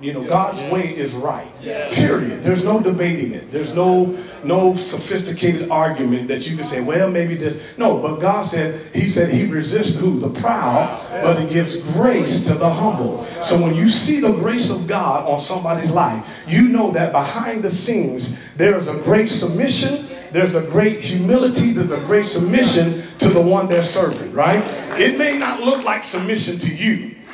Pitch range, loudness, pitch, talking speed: 165-210 Hz, -18 LUFS, 180 Hz, 185 wpm